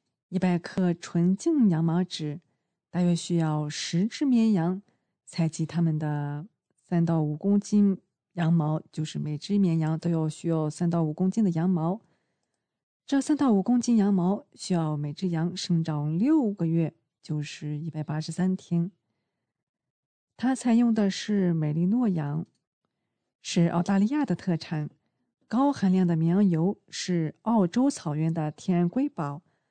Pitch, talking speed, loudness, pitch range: 175 Hz, 215 characters per minute, -27 LUFS, 160-200 Hz